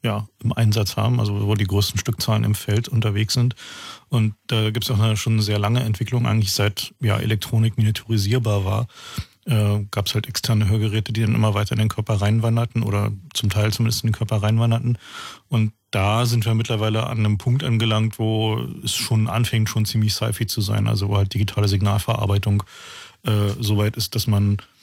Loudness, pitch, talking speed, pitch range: -21 LUFS, 110 Hz, 195 wpm, 105-115 Hz